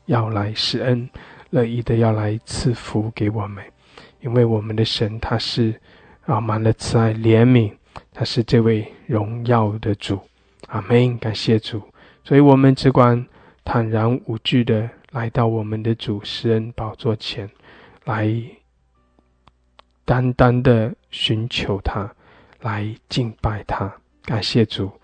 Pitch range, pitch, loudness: 110-120 Hz, 115 Hz, -20 LUFS